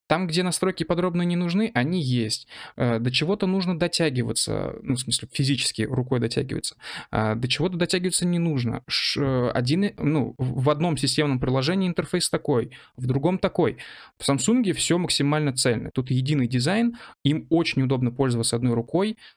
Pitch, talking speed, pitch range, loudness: 145 Hz, 150 wpm, 130-175 Hz, -24 LUFS